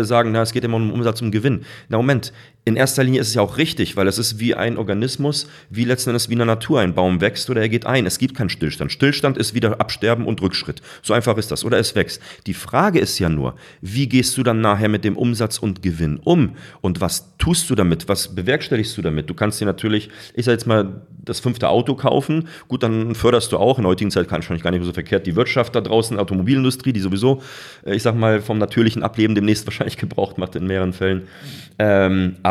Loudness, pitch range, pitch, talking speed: -19 LUFS, 100-125 Hz, 110 Hz, 245 wpm